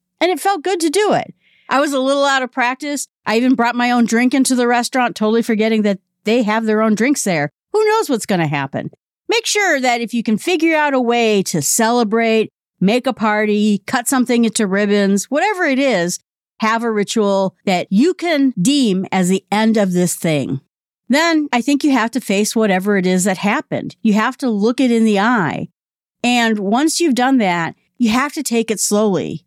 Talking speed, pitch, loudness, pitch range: 210 wpm, 230 Hz, -16 LUFS, 205-265 Hz